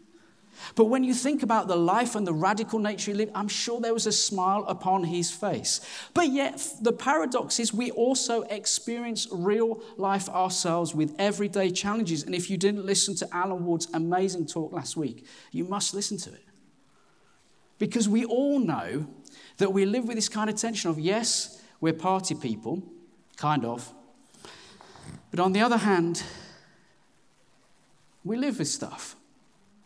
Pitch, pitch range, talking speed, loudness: 200 Hz, 180-225 Hz, 165 wpm, -27 LUFS